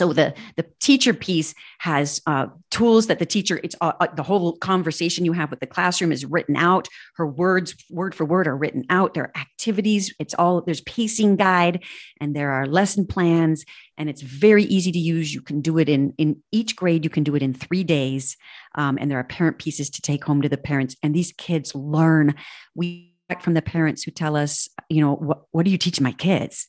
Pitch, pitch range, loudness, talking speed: 165 Hz, 150-180 Hz, -21 LUFS, 220 wpm